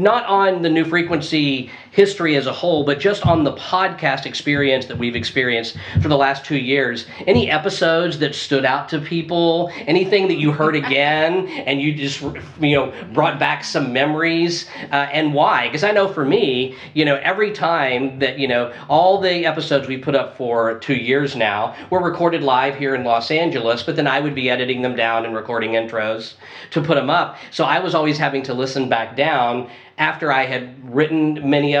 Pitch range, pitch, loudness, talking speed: 130-165 Hz, 140 Hz, -18 LUFS, 200 wpm